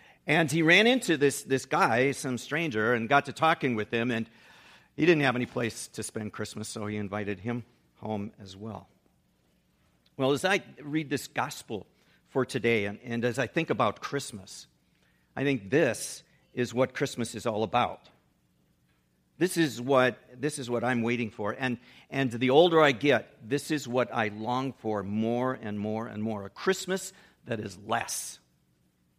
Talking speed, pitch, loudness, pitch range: 175 wpm, 120 Hz, -28 LUFS, 105-140 Hz